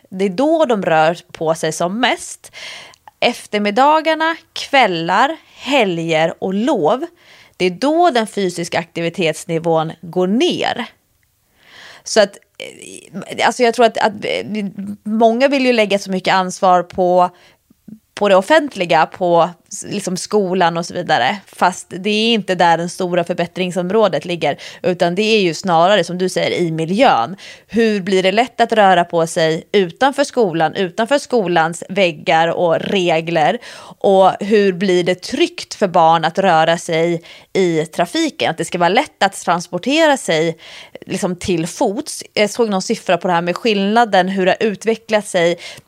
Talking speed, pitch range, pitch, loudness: 155 wpm, 170-225 Hz, 190 Hz, -16 LUFS